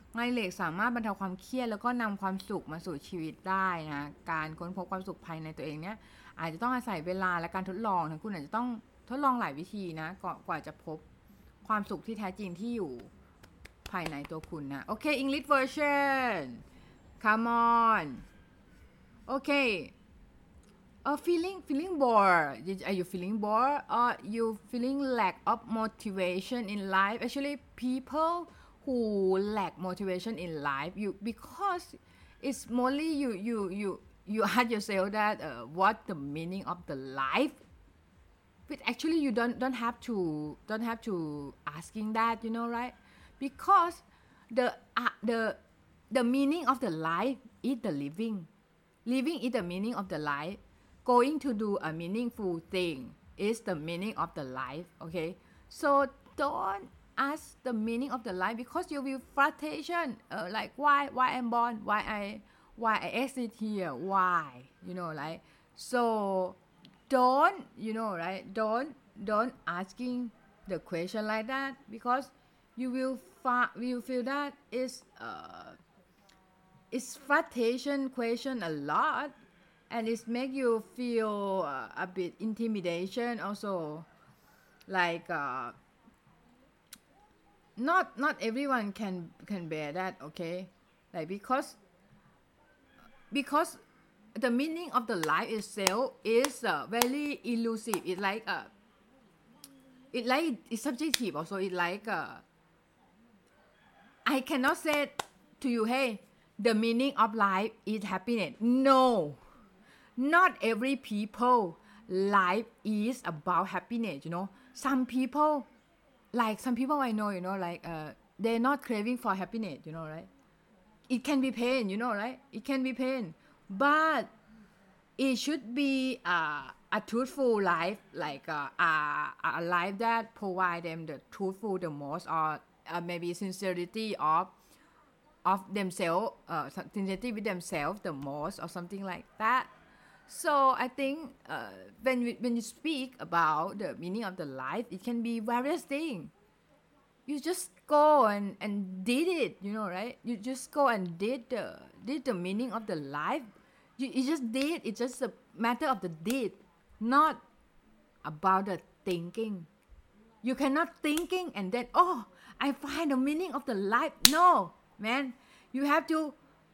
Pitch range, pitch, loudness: 185-255 Hz, 225 Hz, -32 LUFS